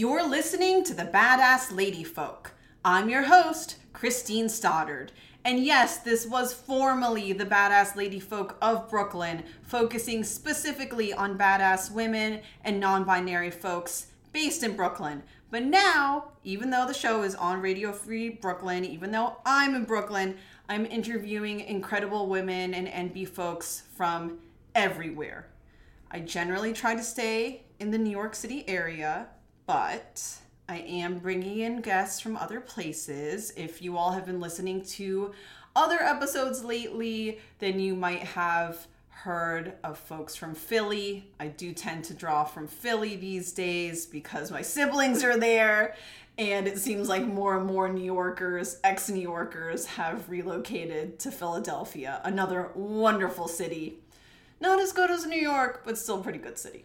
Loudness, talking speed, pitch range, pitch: -28 LUFS, 150 wpm, 180-230 Hz, 200 Hz